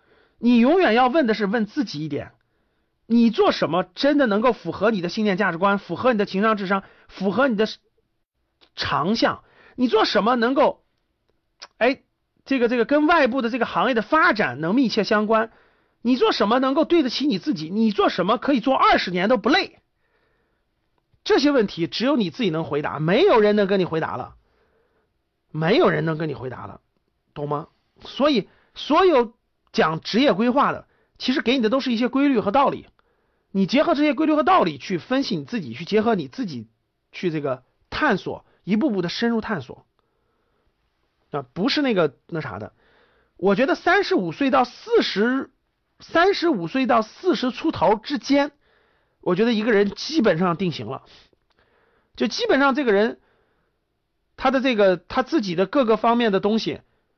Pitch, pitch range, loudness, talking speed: 230 Hz, 190-275 Hz, -21 LUFS, 260 characters per minute